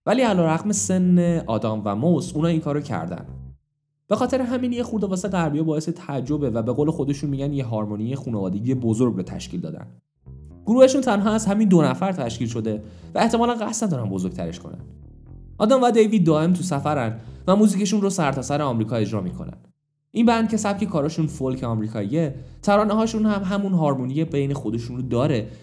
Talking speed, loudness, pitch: 180 wpm, -22 LUFS, 150 Hz